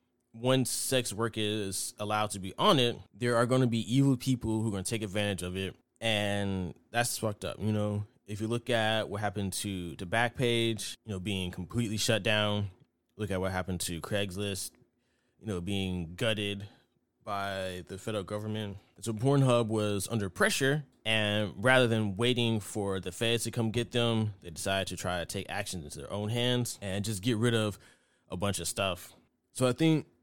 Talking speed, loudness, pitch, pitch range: 195 wpm, -31 LUFS, 105 Hz, 95-120 Hz